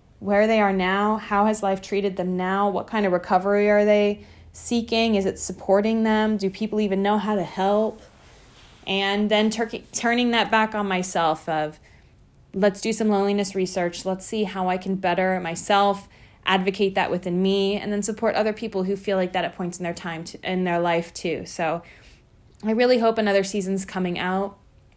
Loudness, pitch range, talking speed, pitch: -23 LUFS, 185-210 Hz, 190 wpm, 195 Hz